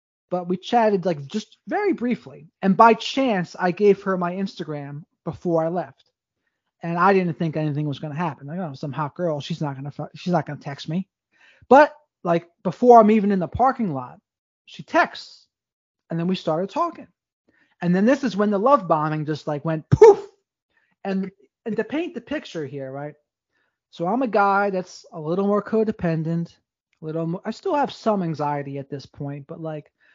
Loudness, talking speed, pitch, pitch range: -22 LUFS, 200 wpm, 175 Hz, 155-215 Hz